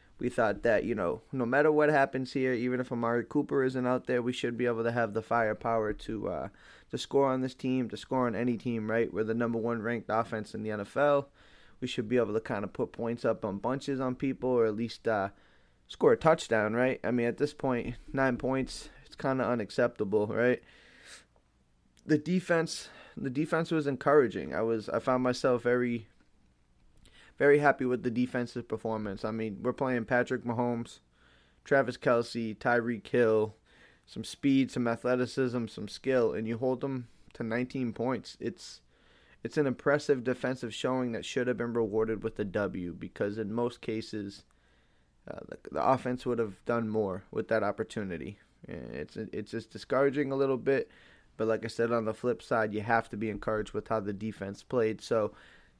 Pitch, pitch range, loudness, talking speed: 120 Hz, 110-130 Hz, -31 LUFS, 185 wpm